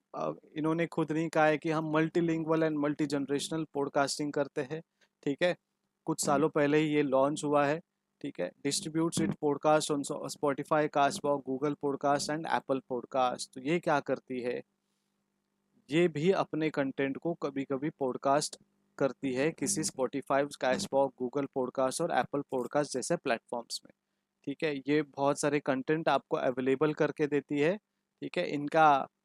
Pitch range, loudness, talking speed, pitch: 140-160 Hz, -31 LUFS, 165 wpm, 150 Hz